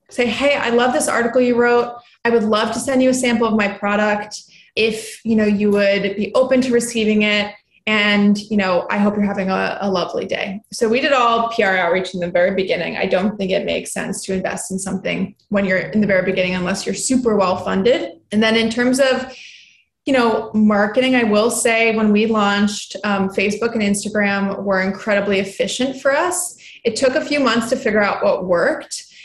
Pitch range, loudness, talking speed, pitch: 200-235 Hz, -17 LUFS, 215 wpm, 210 Hz